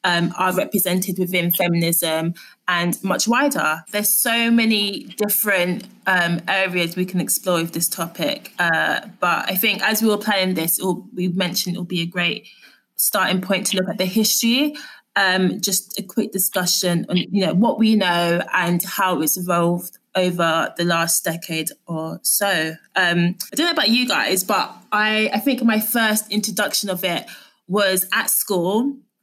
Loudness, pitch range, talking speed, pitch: -19 LUFS, 175-215 Hz, 170 wpm, 185 Hz